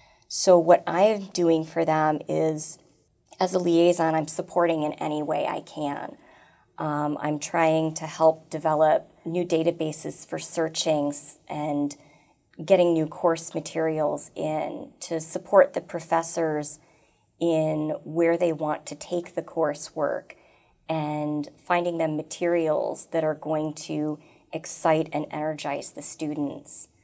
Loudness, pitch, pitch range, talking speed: -25 LUFS, 160 Hz, 150-170 Hz, 130 wpm